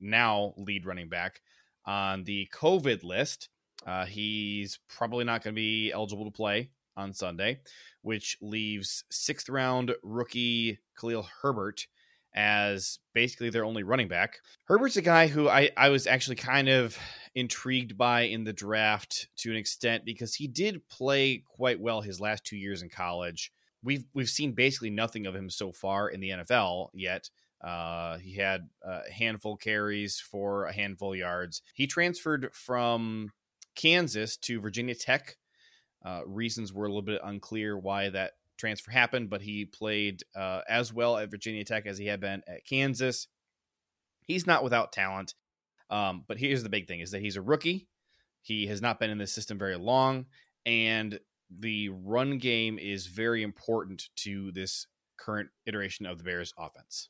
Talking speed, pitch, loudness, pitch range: 170 wpm, 110 Hz, -30 LUFS, 100-120 Hz